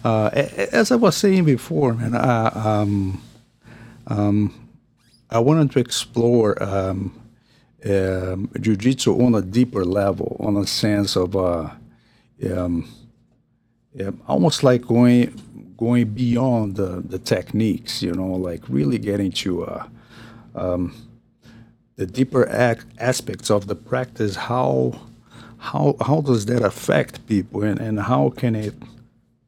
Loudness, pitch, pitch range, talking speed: -20 LUFS, 115 Hz, 100-120 Hz, 130 wpm